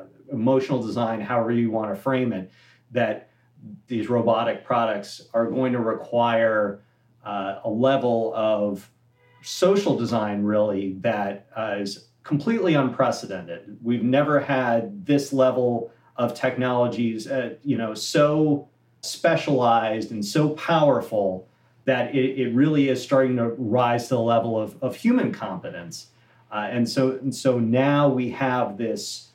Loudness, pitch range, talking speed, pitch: -23 LUFS, 110-135 Hz, 135 wpm, 120 Hz